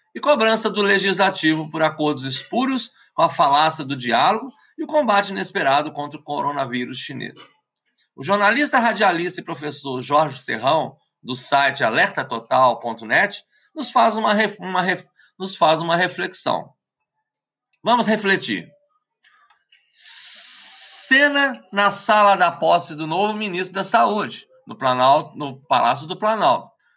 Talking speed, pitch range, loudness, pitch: 130 wpm, 155-245 Hz, -19 LUFS, 195 Hz